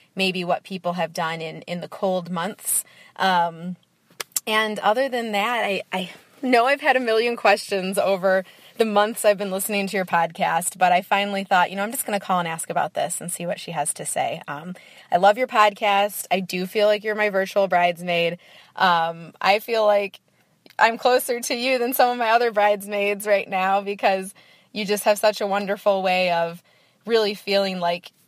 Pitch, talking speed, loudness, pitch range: 200 Hz, 200 wpm, -22 LUFS, 180-210 Hz